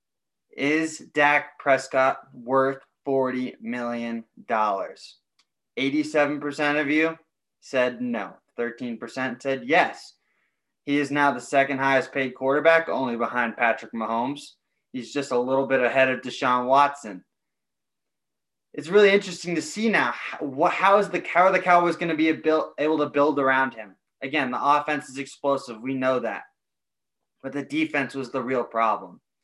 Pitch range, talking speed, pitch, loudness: 130-155 Hz, 150 wpm, 140 Hz, -23 LUFS